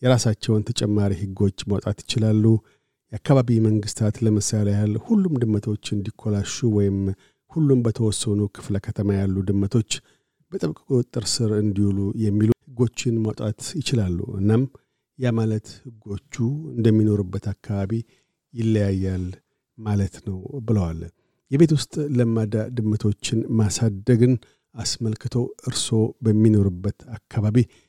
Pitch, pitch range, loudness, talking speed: 110 Hz, 105-120 Hz, -23 LUFS, 100 wpm